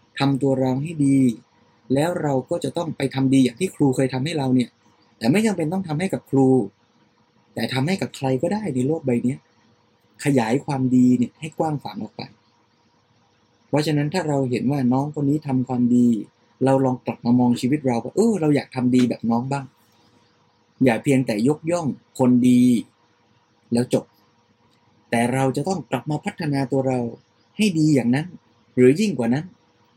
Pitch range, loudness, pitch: 120-145 Hz, -21 LUFS, 130 Hz